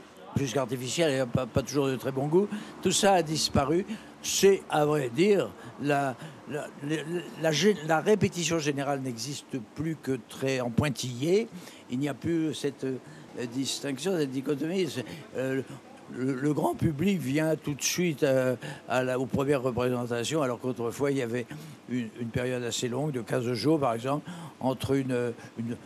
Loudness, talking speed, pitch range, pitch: -29 LUFS, 170 wpm, 125-160 Hz, 140 Hz